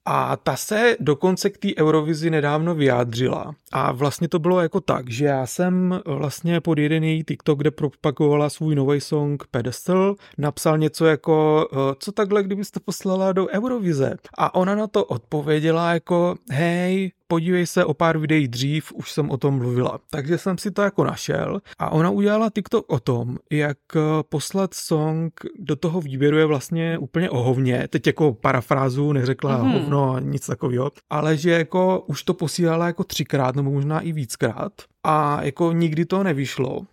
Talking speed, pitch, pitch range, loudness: 165 wpm, 155 Hz, 145-180 Hz, -21 LUFS